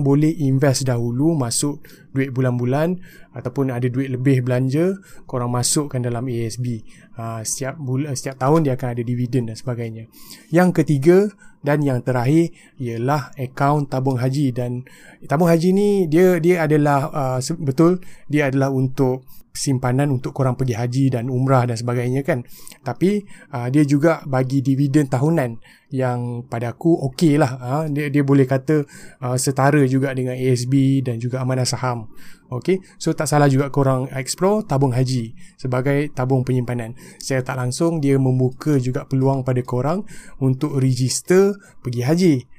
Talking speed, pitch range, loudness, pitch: 150 wpm, 125-155 Hz, -20 LUFS, 135 Hz